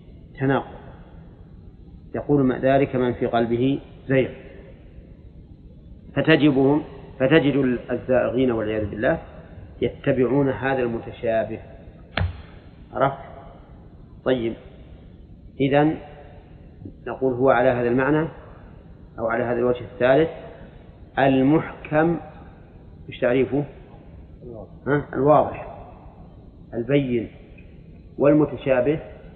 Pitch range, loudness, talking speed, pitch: 110-140 Hz, -22 LUFS, 75 wpm, 125 Hz